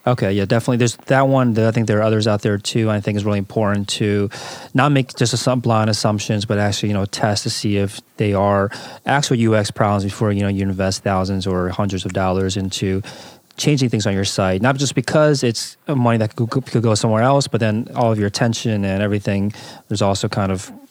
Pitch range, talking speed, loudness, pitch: 100-120 Hz, 225 wpm, -18 LUFS, 110 Hz